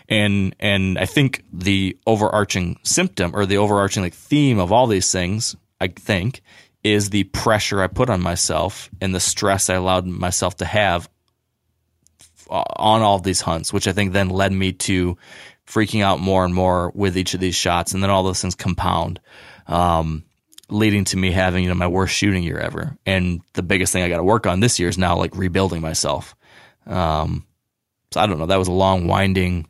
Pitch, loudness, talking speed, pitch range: 95 Hz, -19 LUFS, 200 wpm, 90-105 Hz